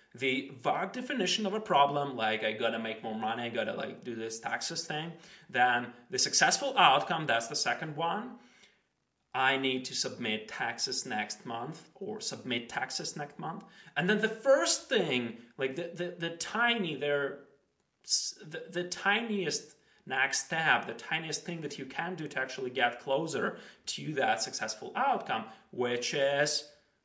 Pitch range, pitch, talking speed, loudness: 130-175 Hz, 145 Hz, 160 wpm, -31 LUFS